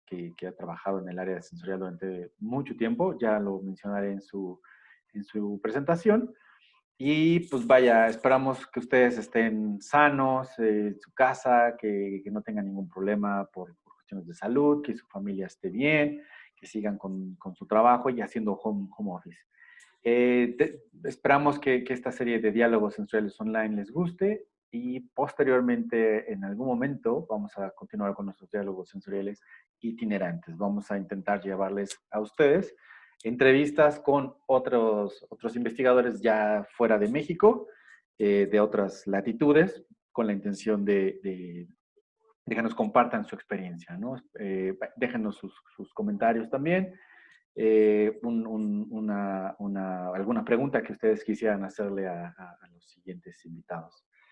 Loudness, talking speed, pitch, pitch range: -28 LUFS, 150 wpm, 110 Hz, 100-135 Hz